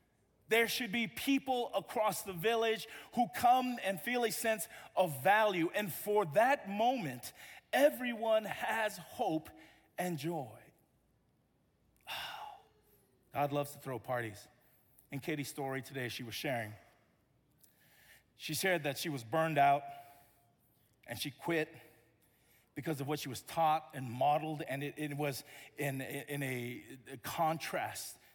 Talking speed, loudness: 135 wpm, -35 LUFS